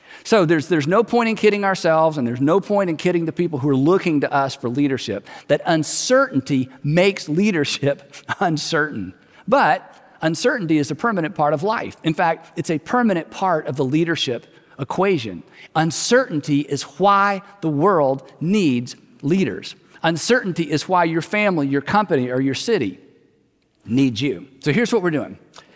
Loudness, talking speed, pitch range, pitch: -19 LUFS, 165 wpm, 145-195 Hz, 160 Hz